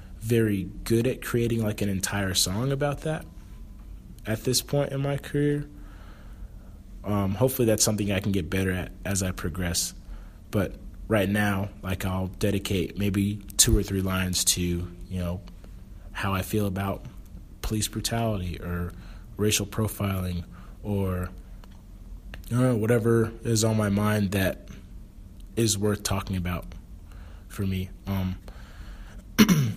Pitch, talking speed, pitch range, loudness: 100 Hz, 135 wpm, 95-110 Hz, -27 LUFS